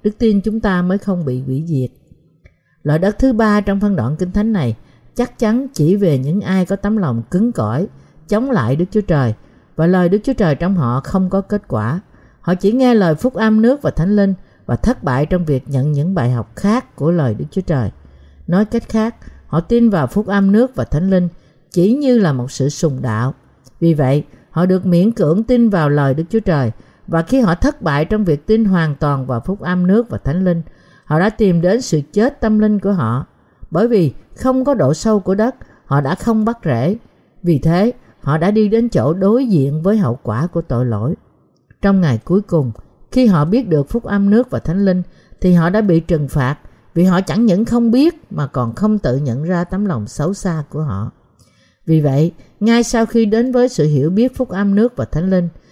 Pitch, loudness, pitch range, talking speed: 180 Hz, -16 LUFS, 150-215 Hz, 225 wpm